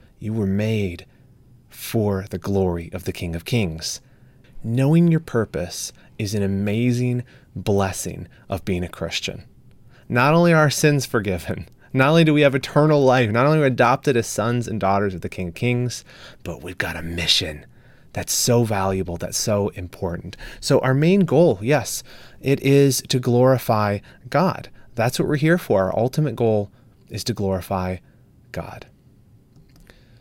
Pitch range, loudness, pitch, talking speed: 100-130 Hz, -20 LUFS, 120 Hz, 165 wpm